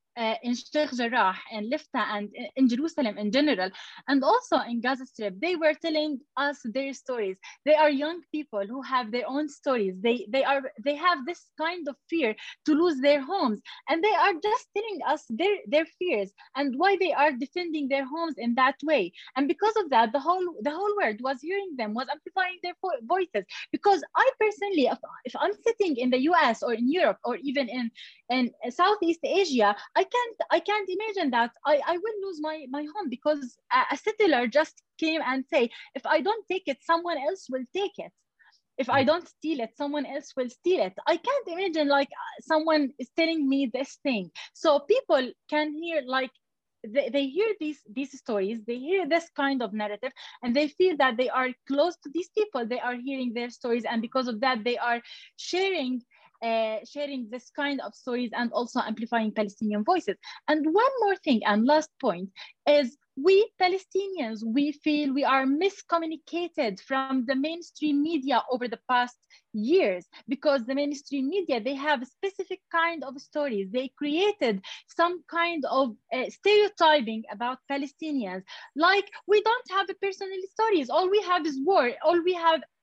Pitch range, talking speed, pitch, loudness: 255-345 Hz, 185 wpm, 290 Hz, -27 LUFS